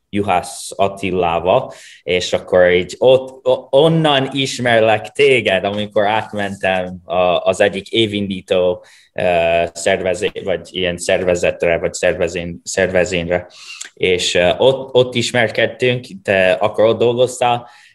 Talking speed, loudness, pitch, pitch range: 95 wpm, -16 LUFS, 100 Hz, 90-125 Hz